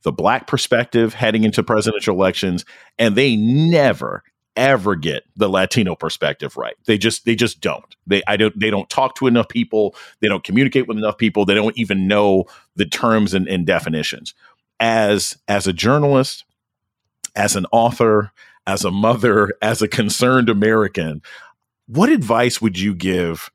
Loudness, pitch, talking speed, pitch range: -17 LUFS, 110 Hz, 165 wpm, 100-115 Hz